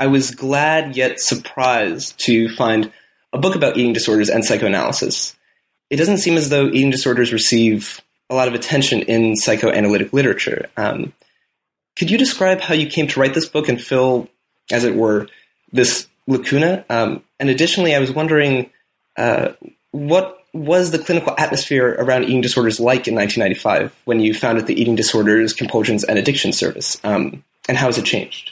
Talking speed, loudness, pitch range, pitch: 170 wpm, -16 LUFS, 115-155 Hz, 130 Hz